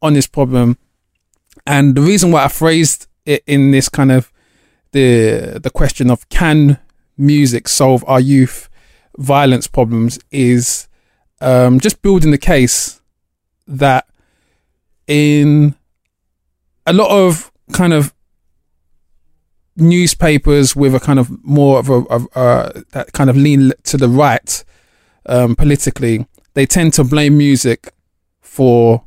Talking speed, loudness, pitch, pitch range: 130 wpm, -12 LUFS, 135 Hz, 120-145 Hz